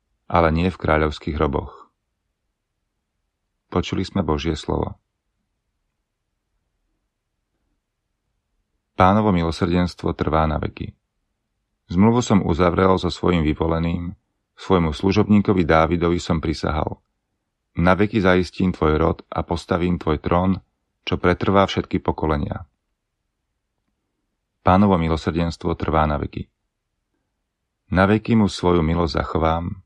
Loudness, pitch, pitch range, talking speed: -20 LUFS, 90 Hz, 80-95 Hz, 100 wpm